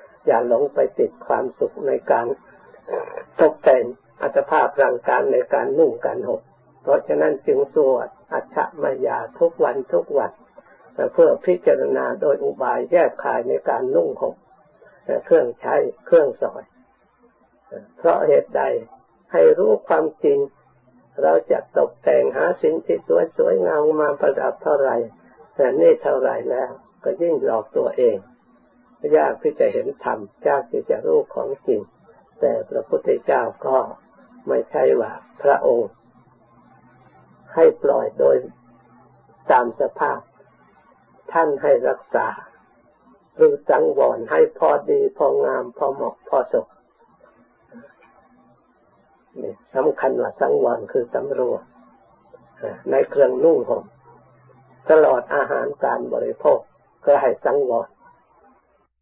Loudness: -20 LUFS